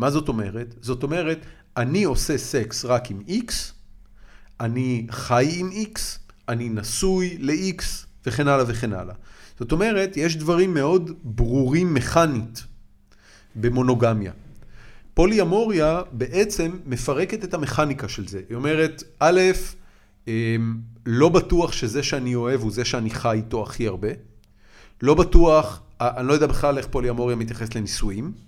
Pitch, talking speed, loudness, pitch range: 125 Hz, 135 wpm, -23 LUFS, 110-155 Hz